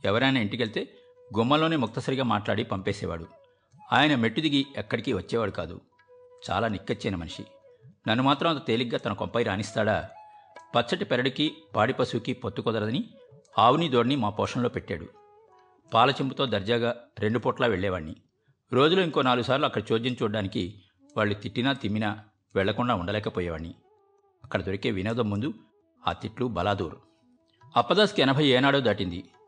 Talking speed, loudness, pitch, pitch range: 120 wpm, -27 LUFS, 120 Hz, 105-140 Hz